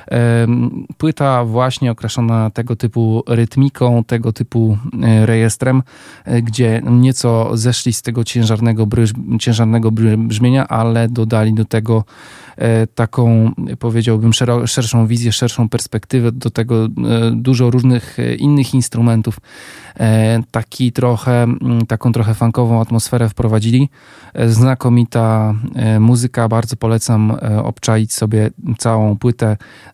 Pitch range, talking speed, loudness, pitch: 115-120 Hz, 100 wpm, -14 LUFS, 115 Hz